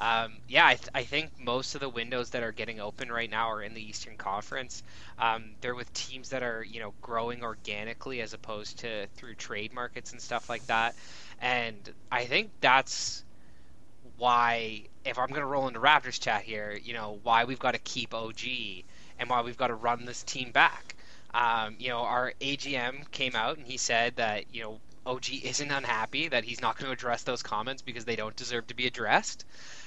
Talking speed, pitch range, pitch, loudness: 205 wpm, 110-125 Hz, 120 Hz, -30 LUFS